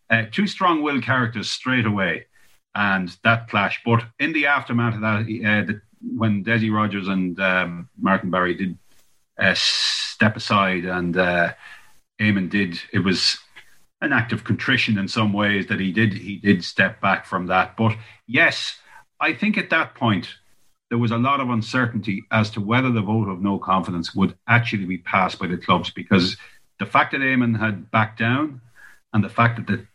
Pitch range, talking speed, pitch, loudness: 95-120 Hz, 185 wpm, 110 Hz, -21 LUFS